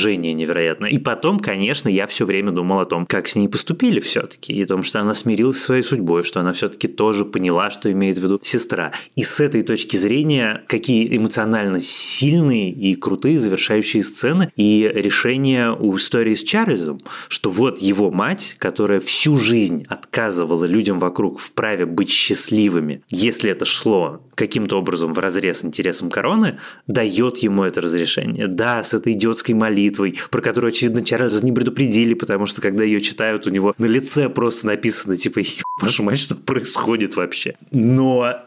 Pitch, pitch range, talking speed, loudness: 110 Hz, 95-120 Hz, 165 wpm, -18 LUFS